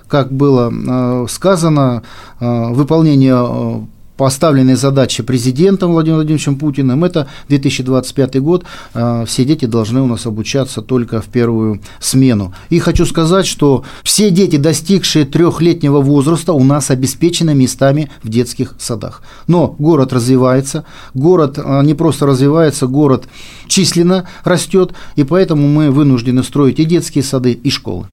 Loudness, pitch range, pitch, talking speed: -12 LUFS, 125-160 Hz, 140 Hz, 125 wpm